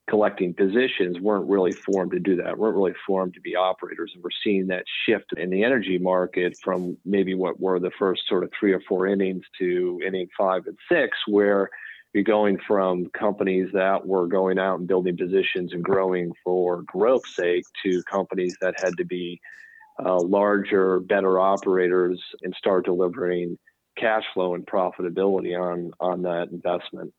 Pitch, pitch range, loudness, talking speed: 95 Hz, 90-95 Hz, -24 LUFS, 170 wpm